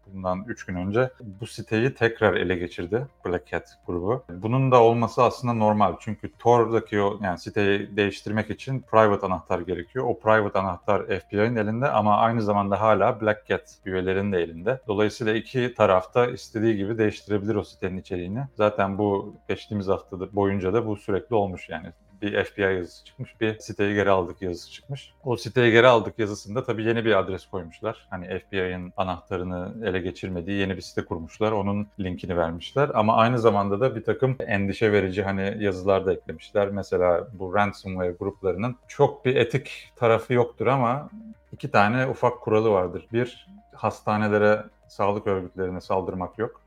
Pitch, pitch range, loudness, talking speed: 105 Hz, 95-115 Hz, -24 LUFS, 160 wpm